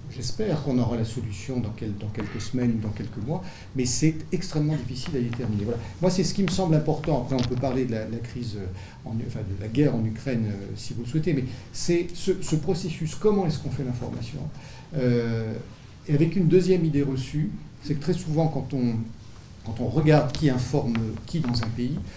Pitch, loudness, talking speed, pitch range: 130 Hz, -26 LUFS, 210 wpm, 115-155 Hz